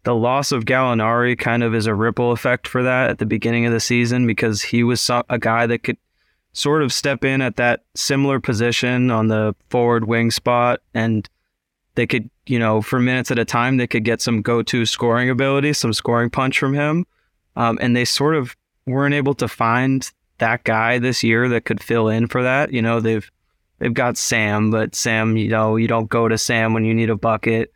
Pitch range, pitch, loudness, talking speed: 115-125 Hz, 120 Hz, -18 LUFS, 215 wpm